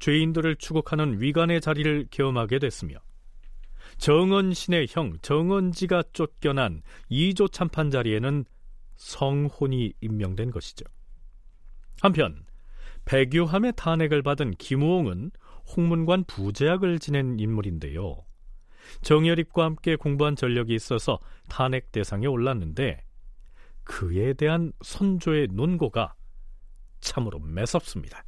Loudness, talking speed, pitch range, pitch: -25 LUFS, 255 characters per minute, 110-165 Hz, 140 Hz